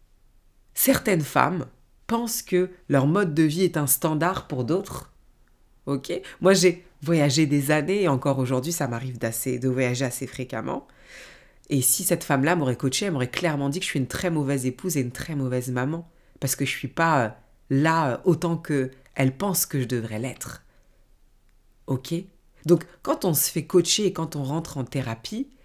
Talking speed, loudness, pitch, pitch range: 180 wpm, -24 LUFS, 145 Hz, 130-175 Hz